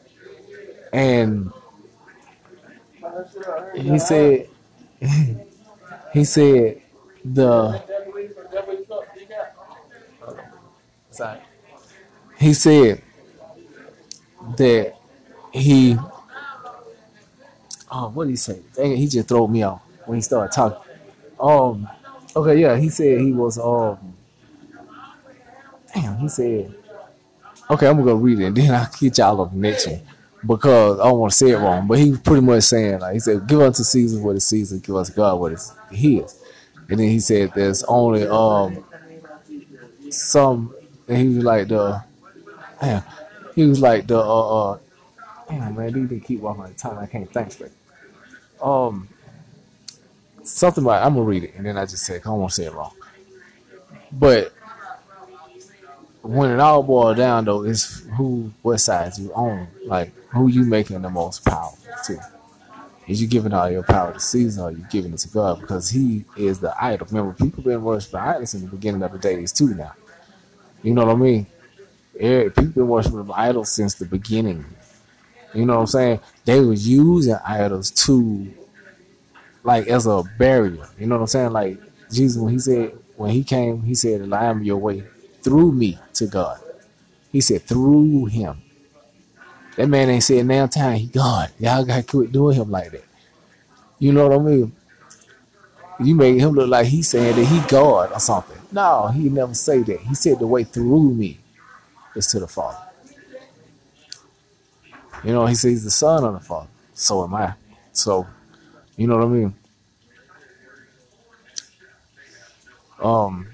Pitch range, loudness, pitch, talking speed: 105-140 Hz, -18 LUFS, 120 Hz, 165 wpm